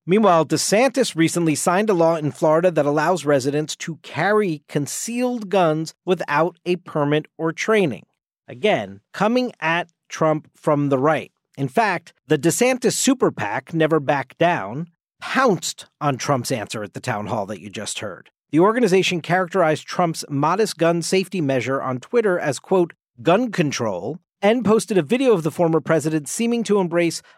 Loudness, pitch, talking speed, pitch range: -20 LUFS, 165 Hz, 160 wpm, 150-190 Hz